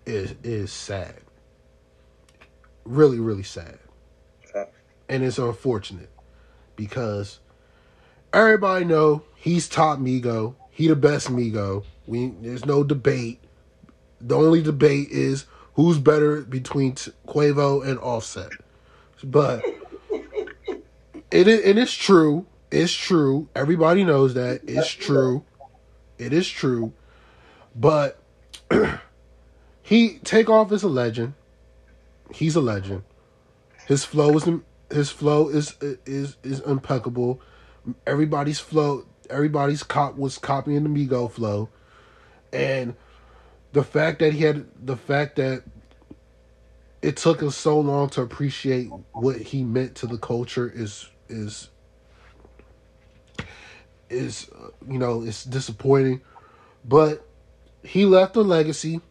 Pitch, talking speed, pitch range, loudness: 135 Hz, 110 wpm, 110-150 Hz, -22 LUFS